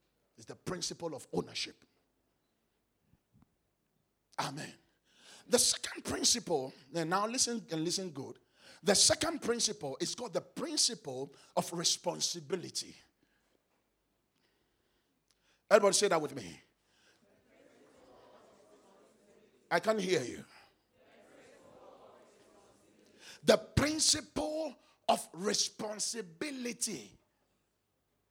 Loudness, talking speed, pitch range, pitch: -32 LUFS, 80 wpm, 175-245 Hz, 205 Hz